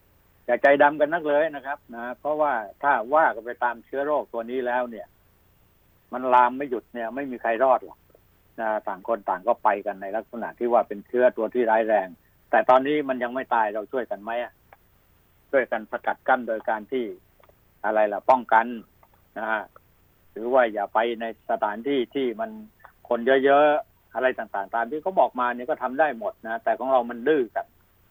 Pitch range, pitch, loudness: 115-140 Hz, 125 Hz, -24 LUFS